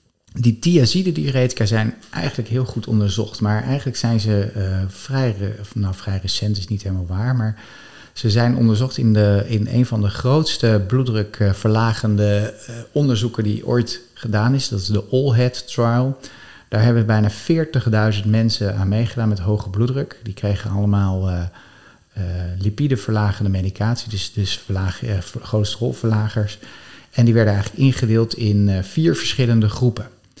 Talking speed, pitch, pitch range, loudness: 155 wpm, 110 Hz, 105-120 Hz, -19 LUFS